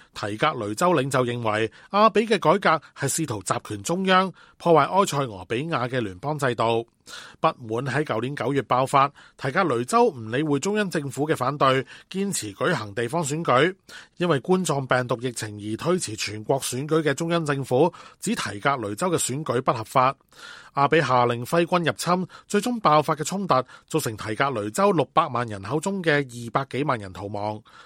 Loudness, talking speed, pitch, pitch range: -24 LUFS, 280 characters per minute, 140 Hz, 120-170 Hz